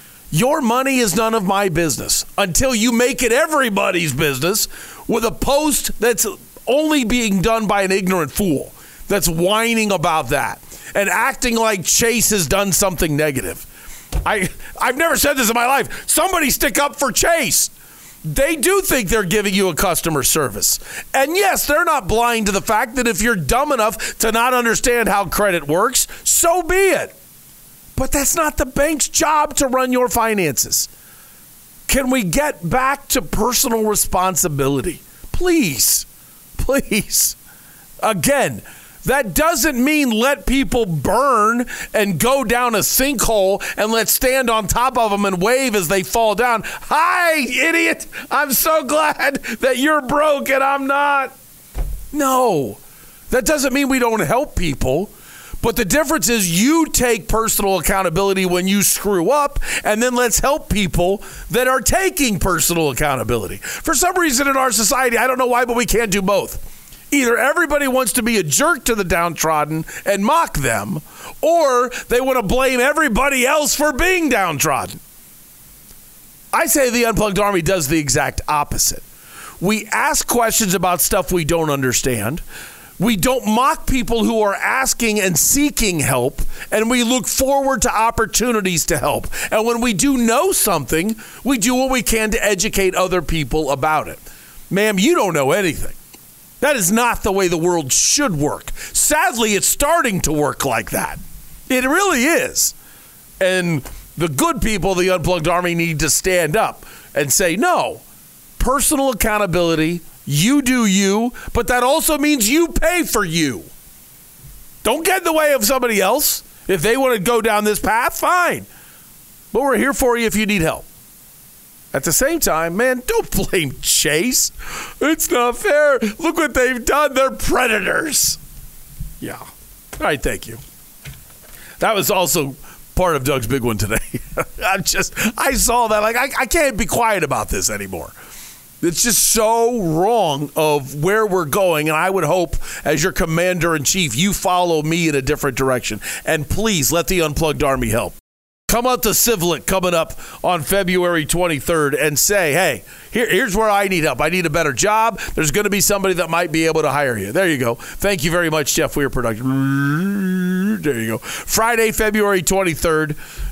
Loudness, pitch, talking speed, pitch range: -16 LUFS, 220 Hz, 170 wpm, 175-260 Hz